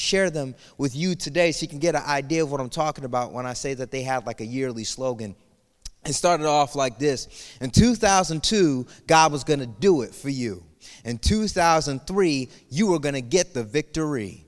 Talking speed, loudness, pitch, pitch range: 205 wpm, -23 LUFS, 145 Hz, 130-160 Hz